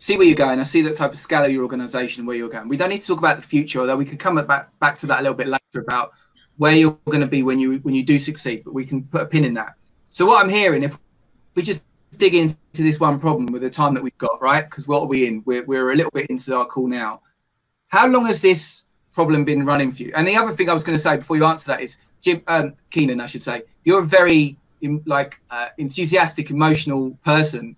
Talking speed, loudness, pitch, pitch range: 275 wpm, -19 LUFS, 145 Hz, 130-160 Hz